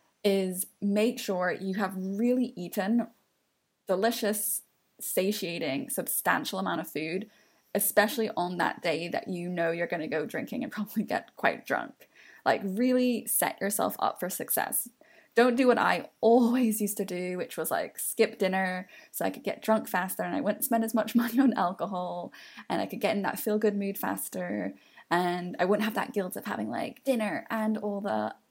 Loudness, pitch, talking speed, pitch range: -29 LUFS, 205 Hz, 185 wpm, 185-230 Hz